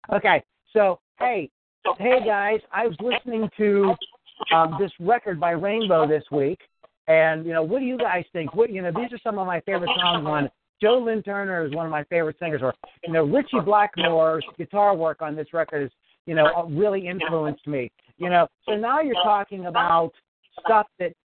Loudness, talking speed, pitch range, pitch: -23 LUFS, 195 wpm, 160-210 Hz, 175 Hz